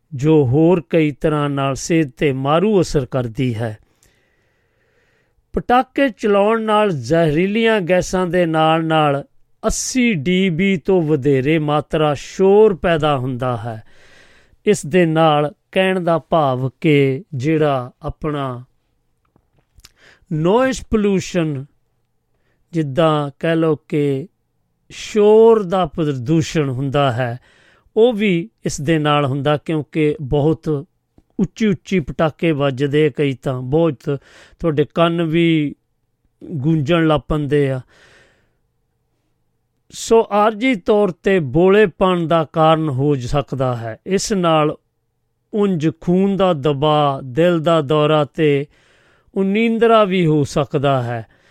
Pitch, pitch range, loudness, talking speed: 155 Hz, 140-185 Hz, -17 LUFS, 110 wpm